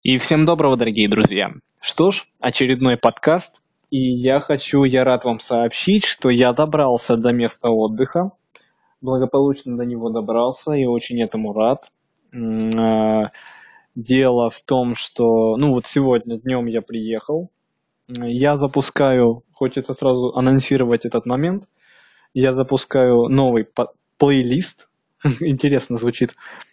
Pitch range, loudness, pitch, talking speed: 120-140 Hz, -18 LUFS, 125 Hz, 120 wpm